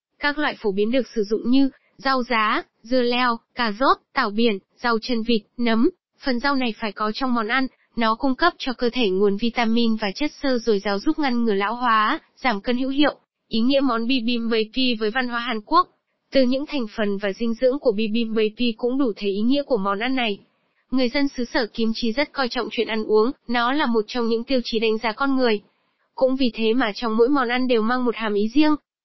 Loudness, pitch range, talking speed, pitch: -22 LUFS, 220-265 Hz, 240 wpm, 240 Hz